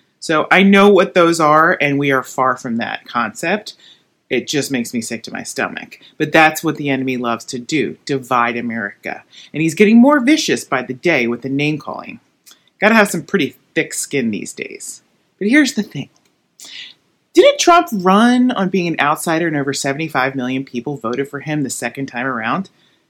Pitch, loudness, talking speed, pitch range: 155 Hz, -15 LUFS, 190 wpm, 135-200 Hz